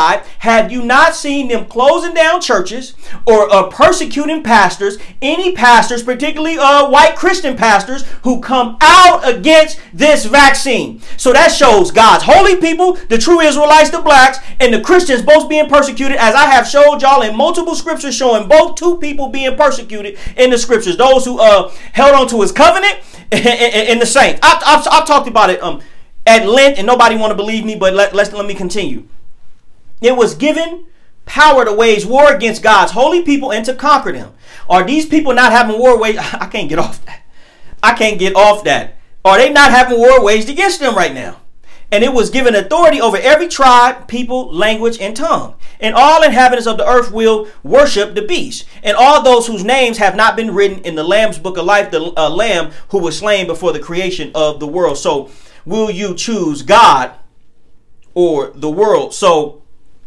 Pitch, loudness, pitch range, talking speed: 250 Hz, -10 LUFS, 215-295 Hz, 195 wpm